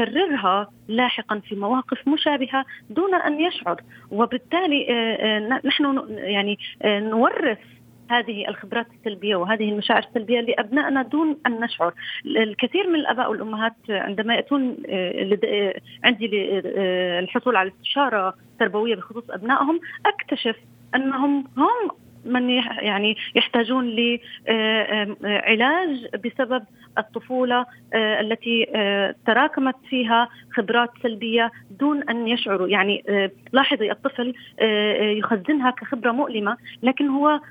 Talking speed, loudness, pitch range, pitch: 95 wpm, -22 LUFS, 210-265 Hz, 235 Hz